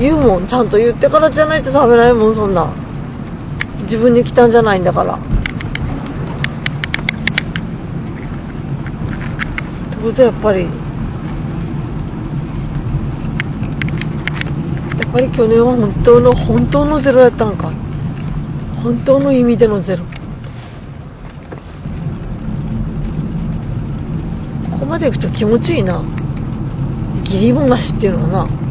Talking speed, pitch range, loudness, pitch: 210 characters per minute, 175-245 Hz, -15 LUFS, 225 Hz